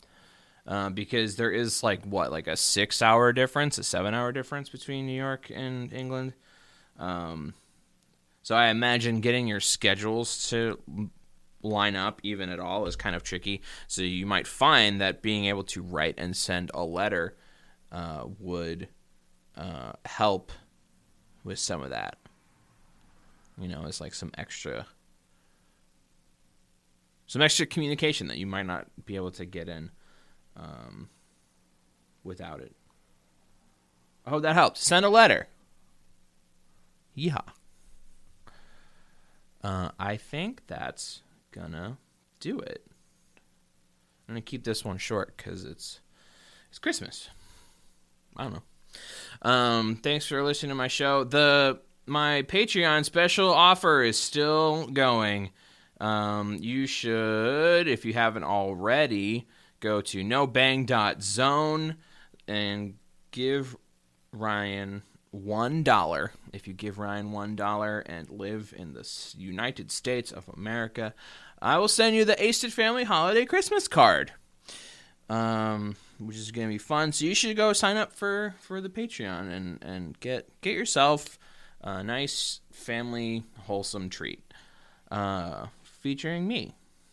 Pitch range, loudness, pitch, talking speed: 95-140 Hz, -27 LUFS, 110 Hz, 130 wpm